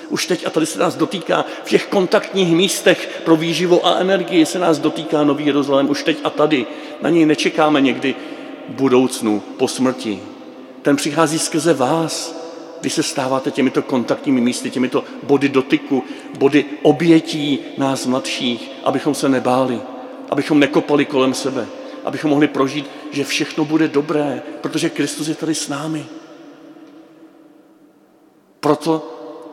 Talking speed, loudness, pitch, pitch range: 140 wpm, -17 LUFS, 150 Hz, 140-165 Hz